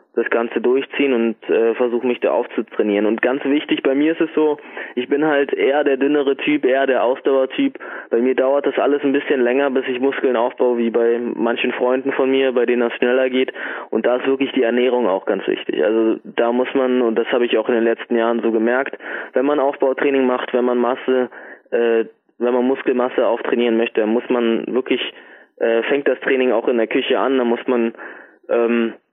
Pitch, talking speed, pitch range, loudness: 125 Hz, 215 wpm, 120-135 Hz, -18 LUFS